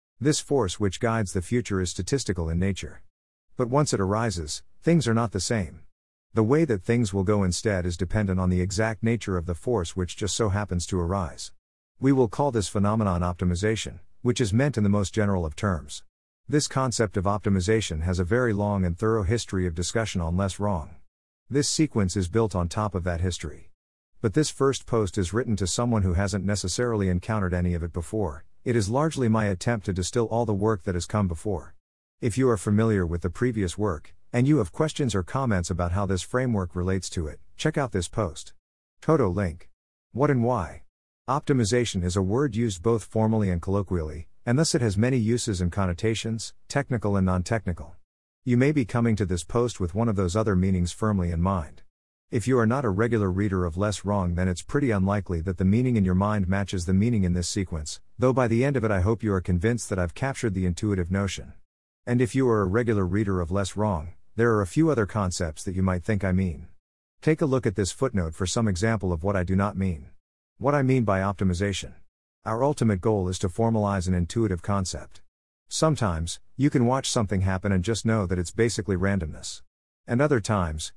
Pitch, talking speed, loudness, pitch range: 100 Hz, 215 wpm, -26 LUFS, 90-115 Hz